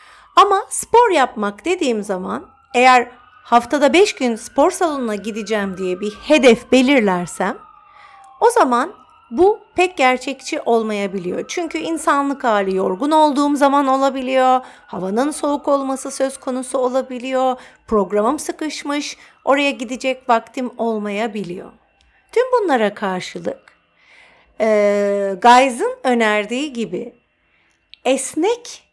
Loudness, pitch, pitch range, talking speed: -17 LUFS, 260 Hz, 225-305 Hz, 100 wpm